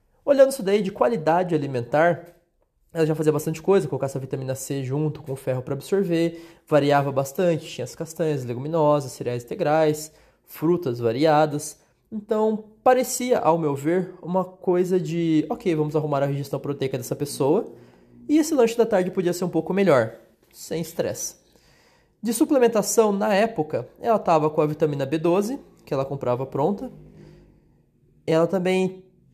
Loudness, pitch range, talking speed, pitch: -23 LUFS, 145-190 Hz, 155 wpm, 165 Hz